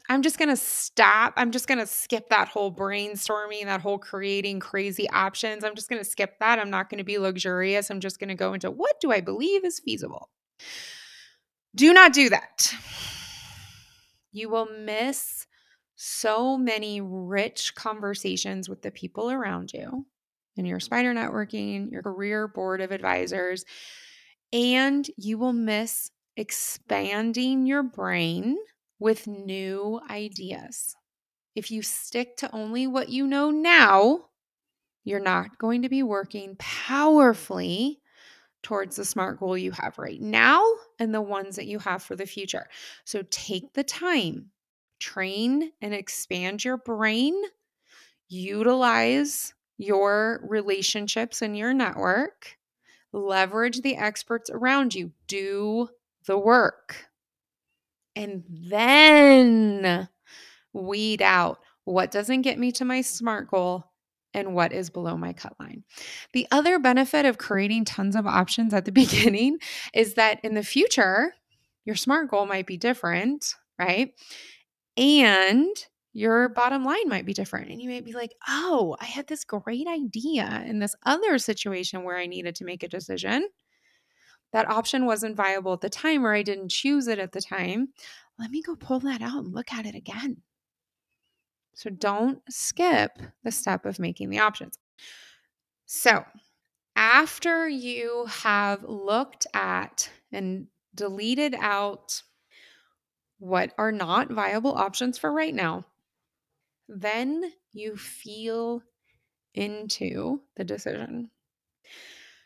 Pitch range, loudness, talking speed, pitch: 195-255 Hz, -24 LUFS, 140 wpm, 220 Hz